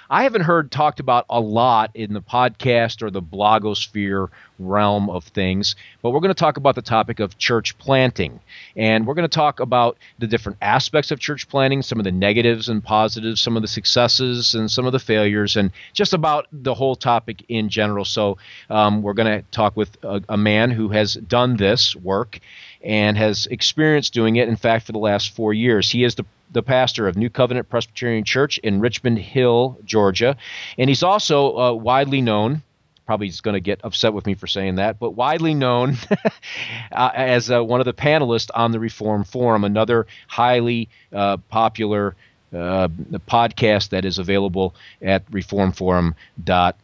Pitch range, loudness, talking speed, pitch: 105-125 Hz, -19 LUFS, 185 wpm, 115 Hz